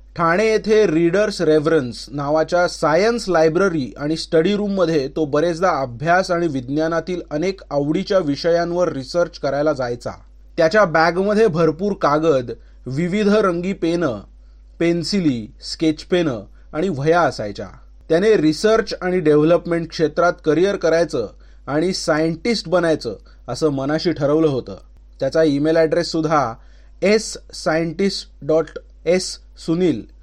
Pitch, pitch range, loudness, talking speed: 165 Hz, 155-180 Hz, -18 LUFS, 115 wpm